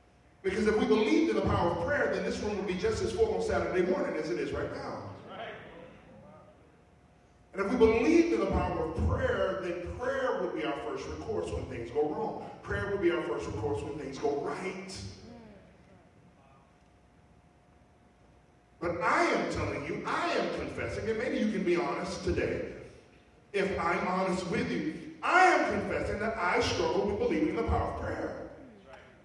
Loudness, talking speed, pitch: -31 LUFS, 180 wpm, 230 Hz